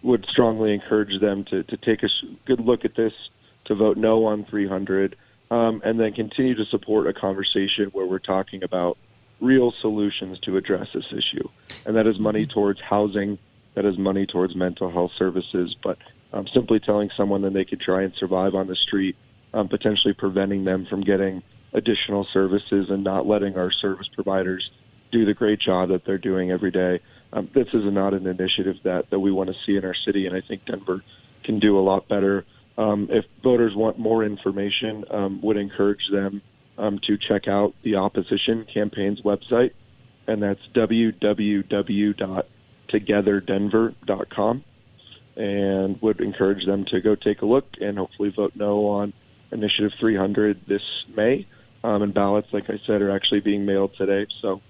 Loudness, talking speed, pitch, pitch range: -23 LUFS, 175 wpm, 100 Hz, 95-110 Hz